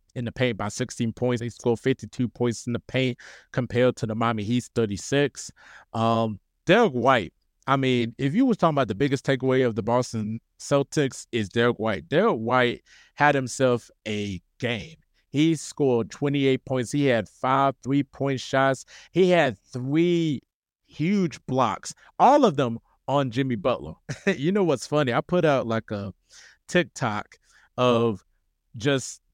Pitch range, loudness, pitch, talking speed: 115-140 Hz, -24 LUFS, 125 Hz, 155 wpm